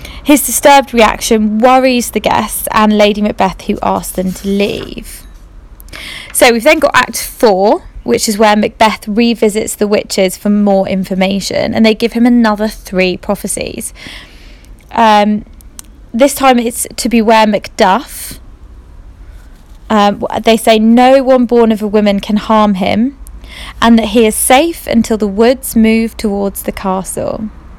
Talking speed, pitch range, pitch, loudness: 145 wpm, 200-235 Hz, 220 Hz, -10 LUFS